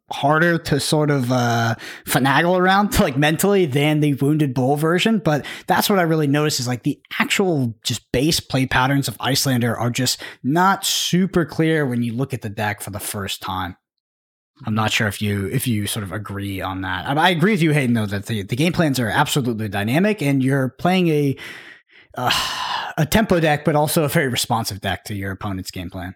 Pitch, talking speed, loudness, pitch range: 135 Hz, 205 wpm, -19 LUFS, 110-160 Hz